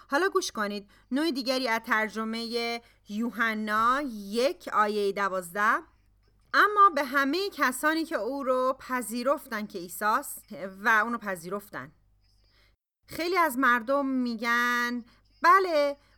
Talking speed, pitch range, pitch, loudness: 110 wpm, 210-285 Hz, 240 Hz, -27 LUFS